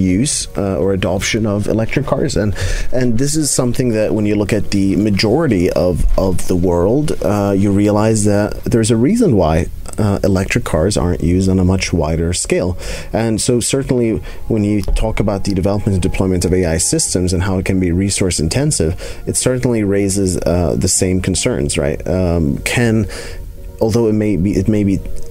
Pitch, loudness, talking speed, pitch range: 95 Hz, -15 LUFS, 185 wpm, 90-110 Hz